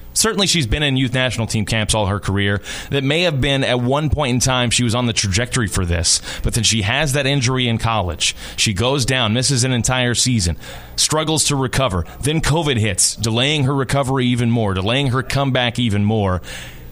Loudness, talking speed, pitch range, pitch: -17 LUFS, 205 wpm, 105-135 Hz, 120 Hz